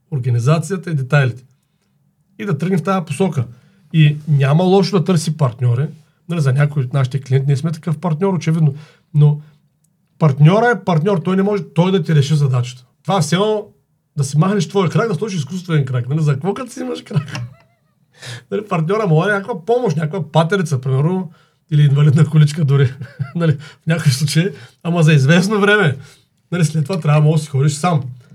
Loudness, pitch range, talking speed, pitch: -16 LUFS, 145-180 Hz, 190 wpm, 155 Hz